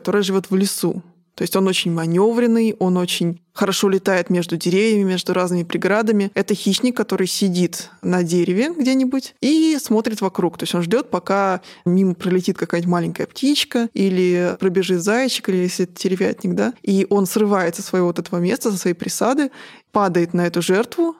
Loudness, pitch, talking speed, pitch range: -19 LUFS, 190 Hz, 175 wpm, 180-220 Hz